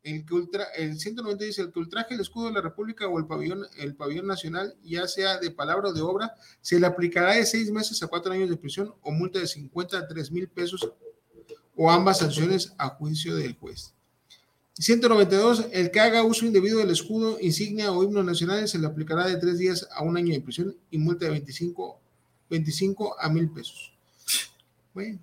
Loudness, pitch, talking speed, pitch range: -26 LUFS, 180 Hz, 195 wpm, 165-205 Hz